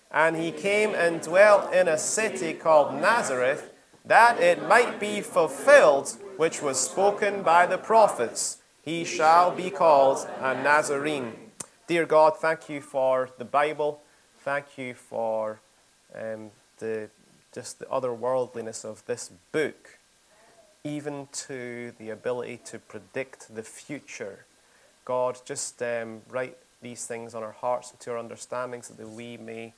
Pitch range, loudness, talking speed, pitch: 120-165 Hz, -24 LUFS, 145 wpm, 140 Hz